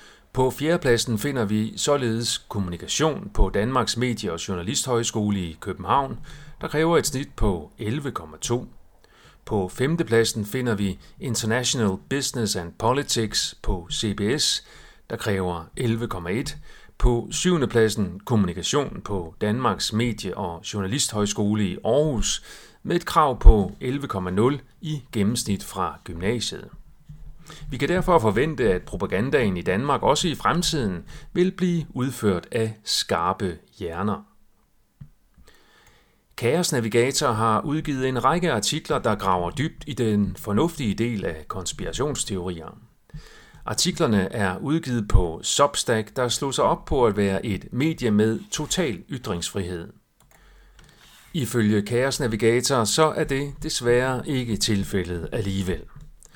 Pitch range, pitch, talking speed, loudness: 105-140 Hz, 115 Hz, 120 wpm, -24 LUFS